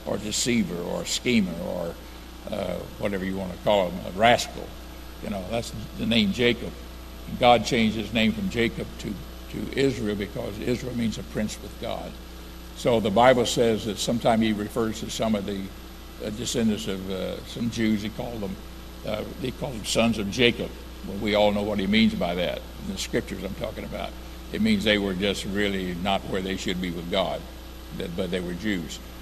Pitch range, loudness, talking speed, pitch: 85-115 Hz, -26 LUFS, 200 wpm, 105 Hz